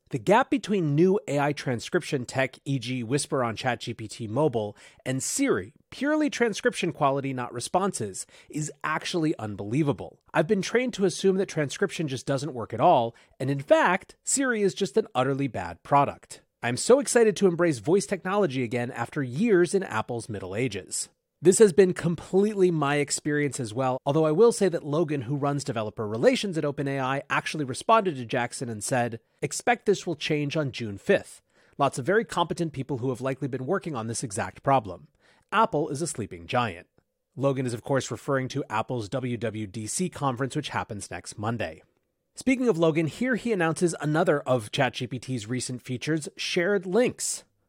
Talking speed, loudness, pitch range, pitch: 170 wpm, -26 LUFS, 125-180 Hz, 145 Hz